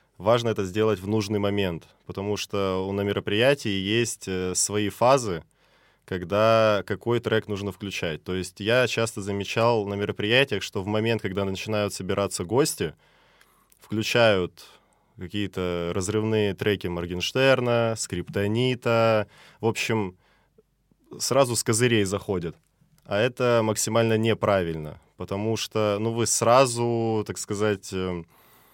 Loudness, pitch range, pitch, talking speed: -25 LUFS, 100-115 Hz, 105 Hz, 115 wpm